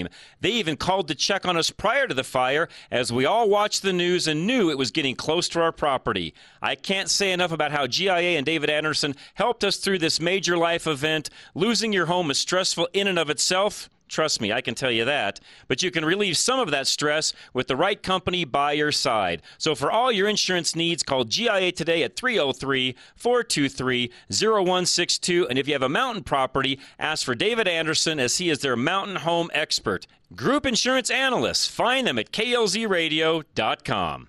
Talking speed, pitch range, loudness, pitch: 195 wpm, 145-190 Hz, -23 LUFS, 165 Hz